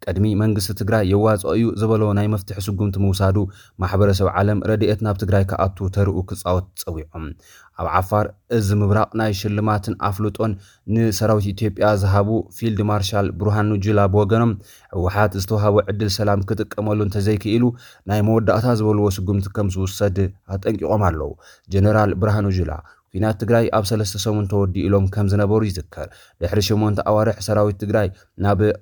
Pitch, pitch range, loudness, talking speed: 105 Hz, 100-110 Hz, -20 LUFS, 140 wpm